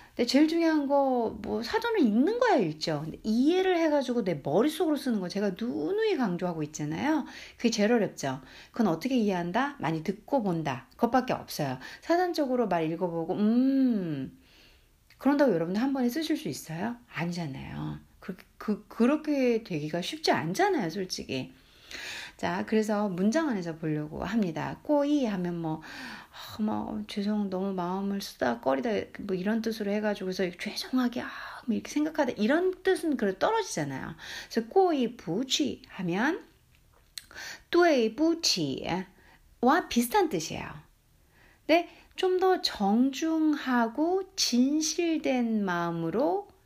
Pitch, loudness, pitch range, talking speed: 235 Hz, -28 LUFS, 185-300 Hz, 300 characters per minute